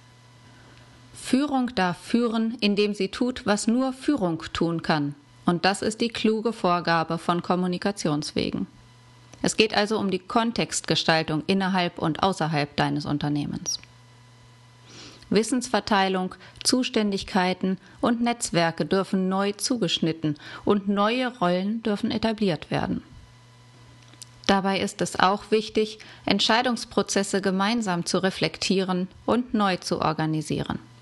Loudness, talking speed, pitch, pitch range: -25 LUFS, 110 wpm, 185 Hz, 155-215 Hz